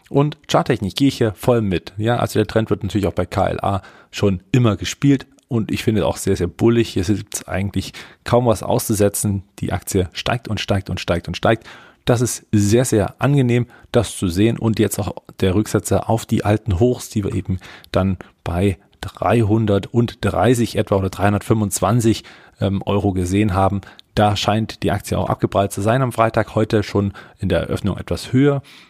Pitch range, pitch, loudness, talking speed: 95-115 Hz, 105 Hz, -19 LUFS, 185 wpm